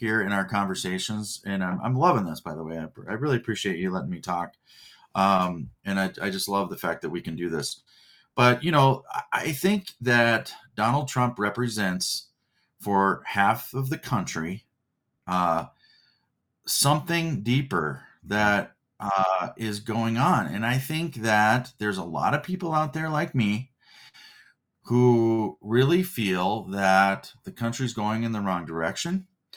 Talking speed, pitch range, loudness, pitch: 160 wpm, 95-135 Hz, -25 LUFS, 115 Hz